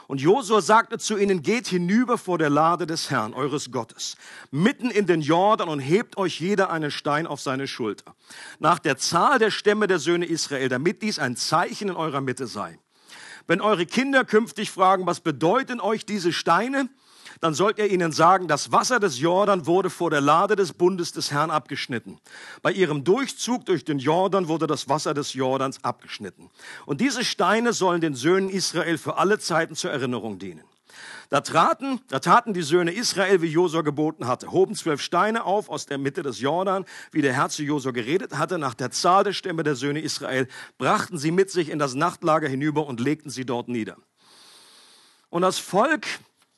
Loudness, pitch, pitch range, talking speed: -23 LUFS, 170 Hz, 145-200 Hz, 190 wpm